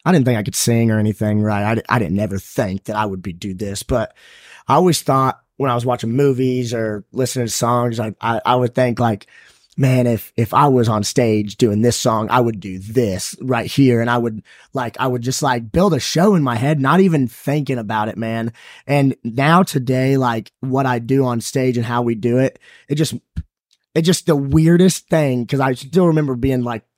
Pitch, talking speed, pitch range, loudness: 125 Hz, 225 wpm, 115-135 Hz, -17 LUFS